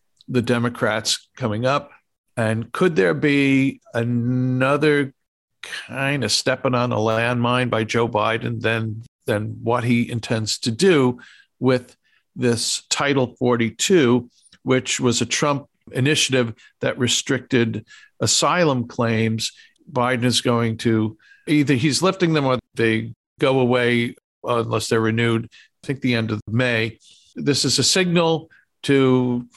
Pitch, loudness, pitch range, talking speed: 120 Hz, -20 LUFS, 115-135 Hz, 130 wpm